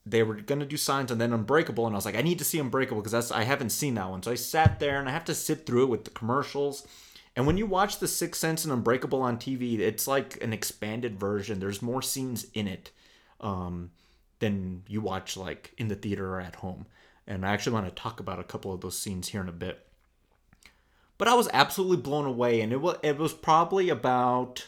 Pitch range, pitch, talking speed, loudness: 100-140 Hz, 120 Hz, 240 wpm, -29 LUFS